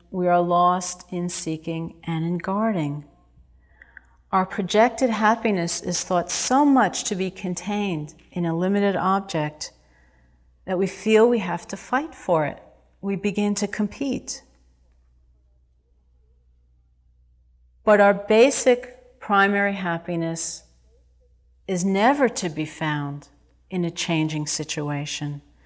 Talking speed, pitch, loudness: 115 wpm, 175 Hz, -23 LUFS